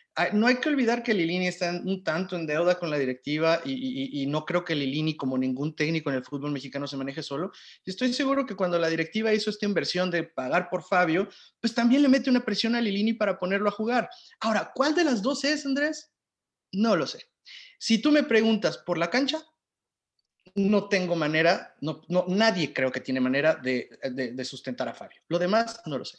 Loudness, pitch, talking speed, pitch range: -26 LUFS, 180 Hz, 215 wpm, 150-225 Hz